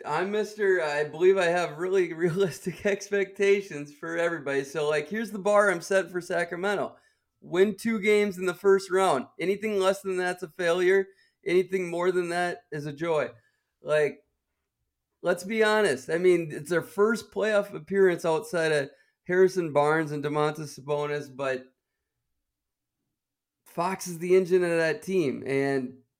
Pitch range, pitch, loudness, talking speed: 150-195 Hz, 180 Hz, -26 LUFS, 155 wpm